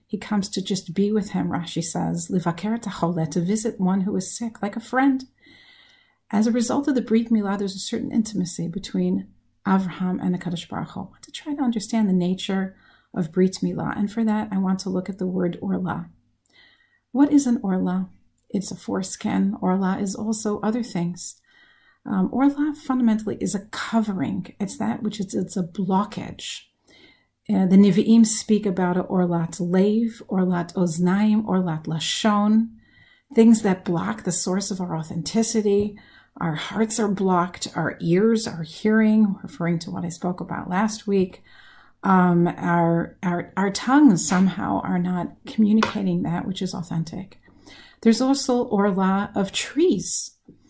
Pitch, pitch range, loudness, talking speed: 195 Hz, 180-220 Hz, -23 LUFS, 155 wpm